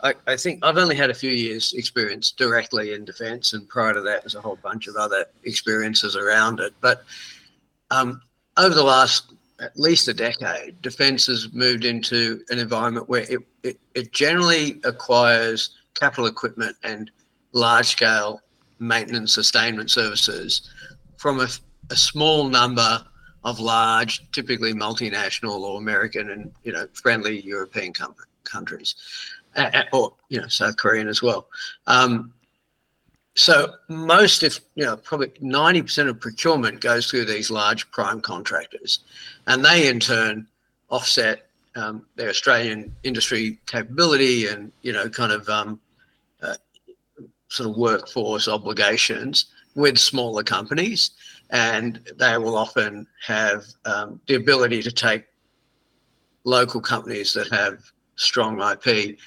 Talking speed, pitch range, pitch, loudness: 135 wpm, 110-140 Hz, 120 Hz, -20 LUFS